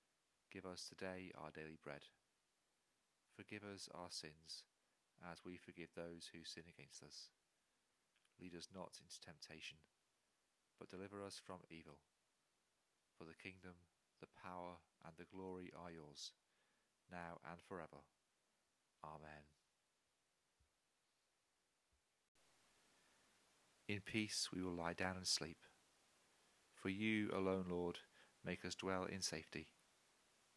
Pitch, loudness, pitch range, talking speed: 90 Hz, -50 LUFS, 80-95 Hz, 115 wpm